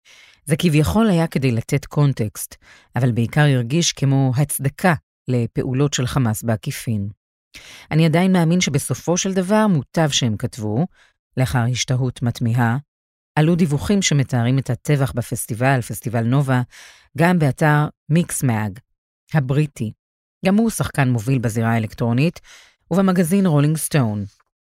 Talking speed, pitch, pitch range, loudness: 115 wpm, 135 Hz, 120-160 Hz, -19 LUFS